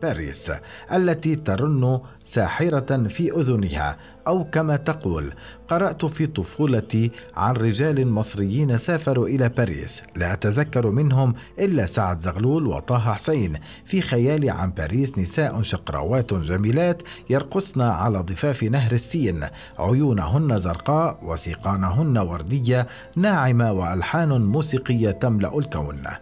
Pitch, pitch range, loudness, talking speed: 120 Hz, 95-145 Hz, -22 LUFS, 110 wpm